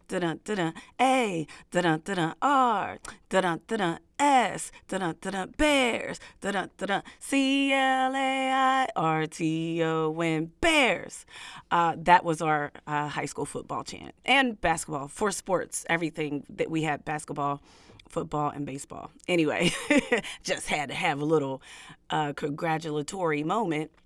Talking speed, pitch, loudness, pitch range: 125 wpm, 165 Hz, -27 LUFS, 155-240 Hz